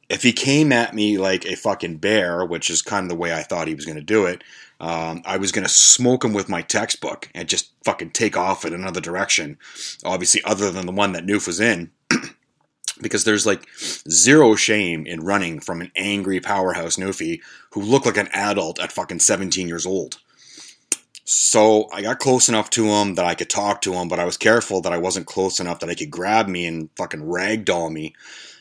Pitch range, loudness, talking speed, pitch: 85-110 Hz, -19 LUFS, 215 wpm, 100 Hz